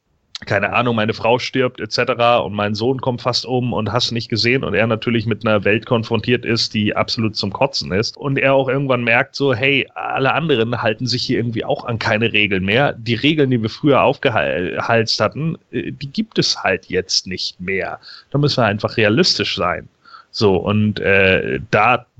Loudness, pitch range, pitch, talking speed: -17 LUFS, 110-130 Hz, 120 Hz, 190 wpm